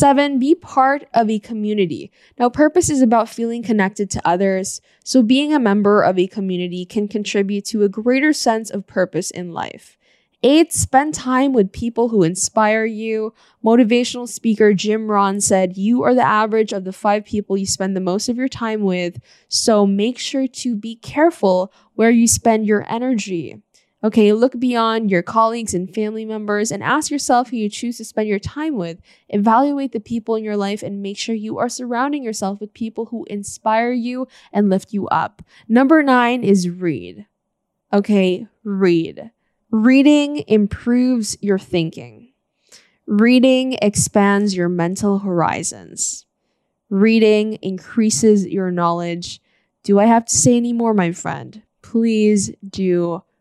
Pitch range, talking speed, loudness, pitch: 195-240 Hz, 160 wpm, -17 LUFS, 215 Hz